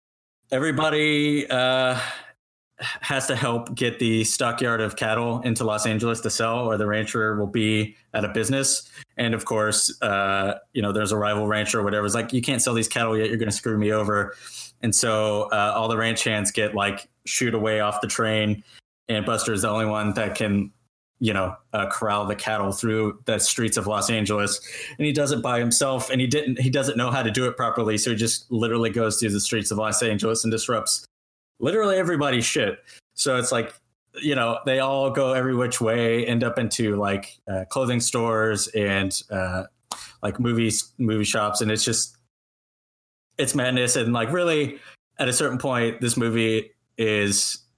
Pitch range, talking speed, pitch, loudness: 105-125 Hz, 195 wpm, 115 Hz, -23 LUFS